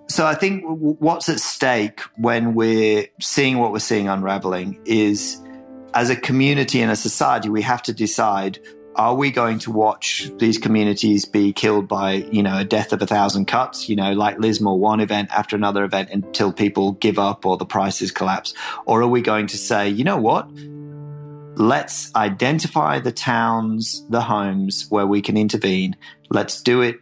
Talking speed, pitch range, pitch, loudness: 180 wpm, 100-125 Hz, 110 Hz, -19 LUFS